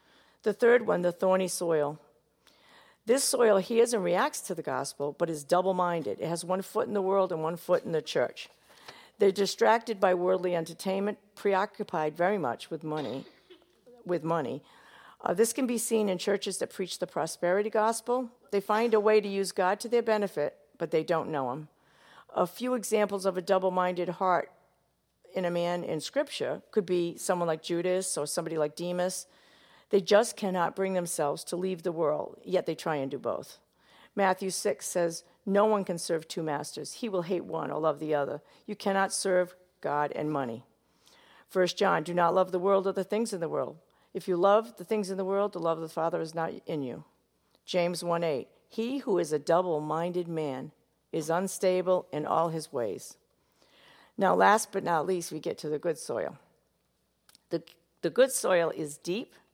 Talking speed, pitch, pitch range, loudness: 190 wpm, 180 Hz, 165-200 Hz, -29 LUFS